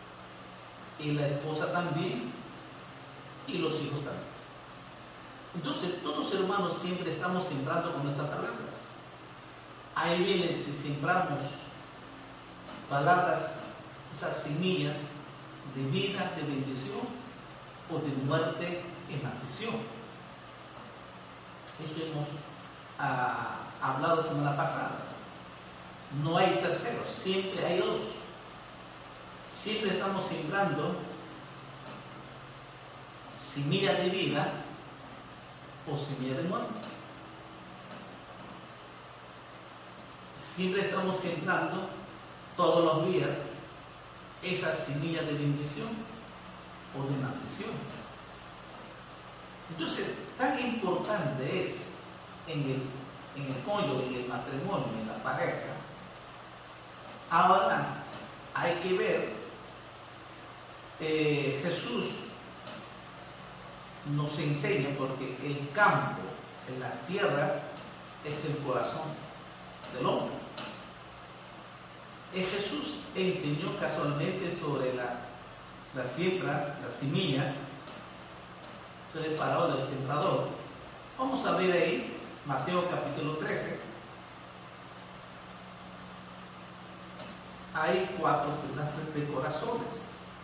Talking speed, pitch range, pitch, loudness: 85 wpm, 135-175 Hz, 150 Hz, -33 LUFS